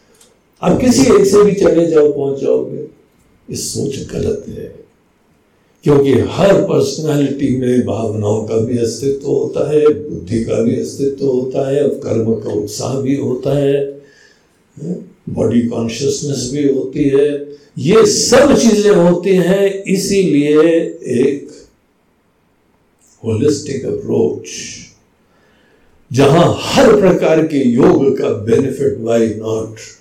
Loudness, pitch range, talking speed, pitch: -13 LUFS, 125-180 Hz, 110 wpm, 140 Hz